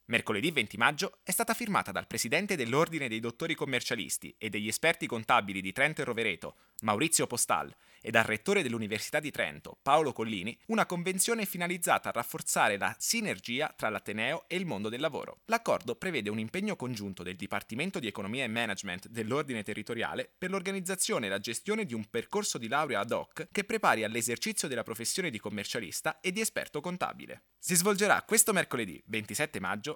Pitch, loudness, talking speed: 150 Hz, -31 LUFS, 170 wpm